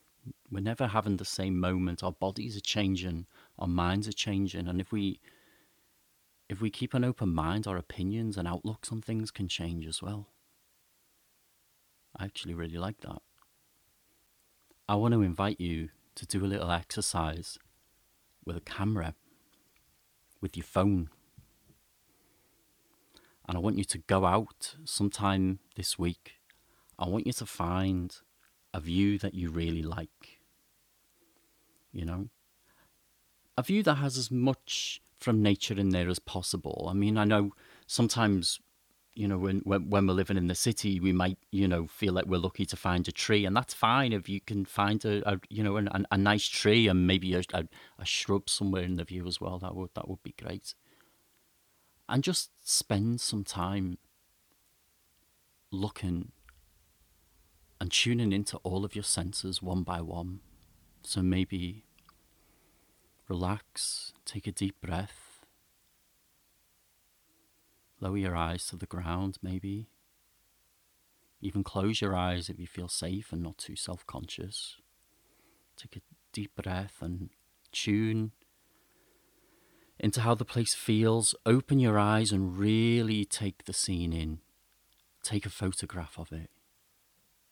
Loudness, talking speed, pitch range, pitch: -31 LUFS, 150 wpm, 90-105 Hz, 95 Hz